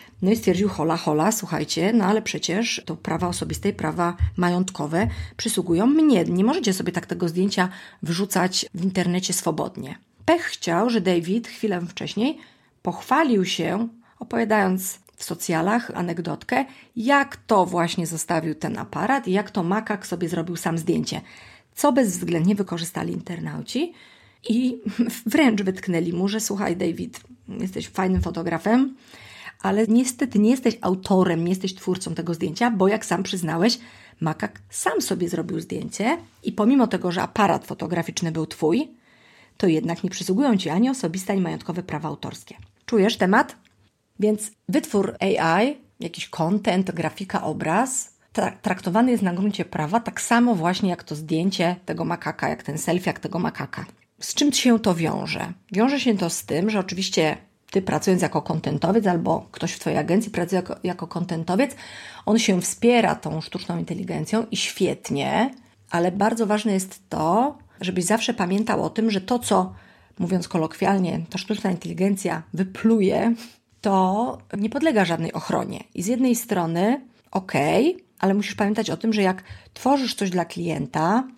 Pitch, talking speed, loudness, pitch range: 190 Hz, 150 wpm, -23 LUFS, 175-225 Hz